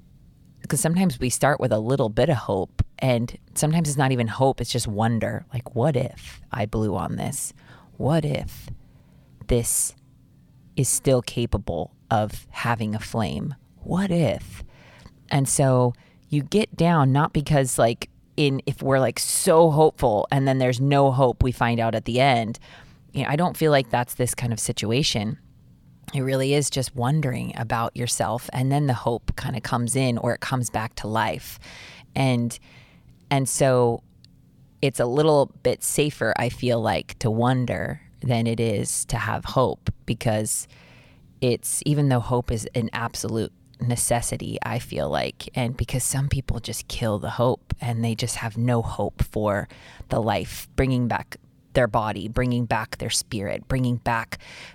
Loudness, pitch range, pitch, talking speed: -24 LUFS, 115-135 Hz, 125 Hz, 170 wpm